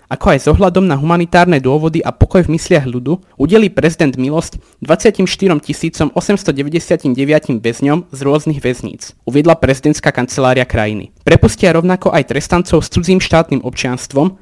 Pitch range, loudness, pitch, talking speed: 135-175 Hz, -13 LUFS, 155 Hz, 135 wpm